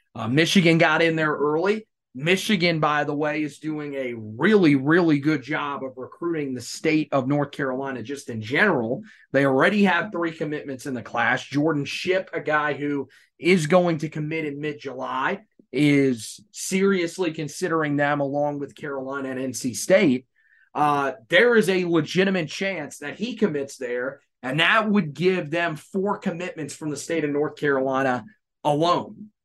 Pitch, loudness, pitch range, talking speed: 150 Hz, -23 LUFS, 140-175 Hz, 165 wpm